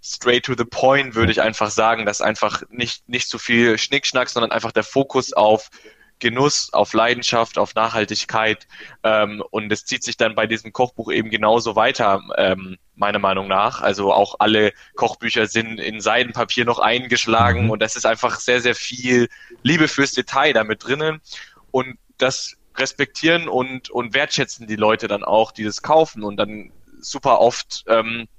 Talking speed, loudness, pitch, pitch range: 170 wpm, -19 LUFS, 115 Hz, 110-130 Hz